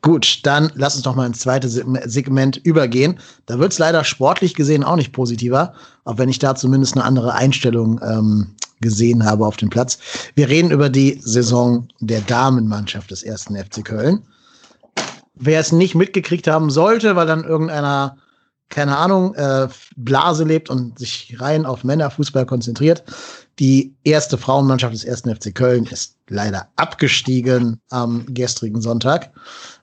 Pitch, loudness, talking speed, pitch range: 130 Hz, -17 LUFS, 155 wpm, 120-155 Hz